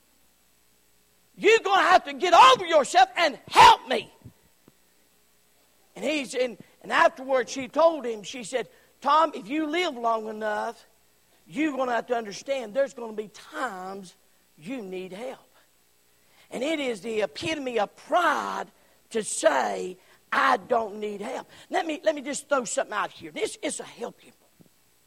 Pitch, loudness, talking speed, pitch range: 235 Hz, -24 LUFS, 165 wpm, 185-300 Hz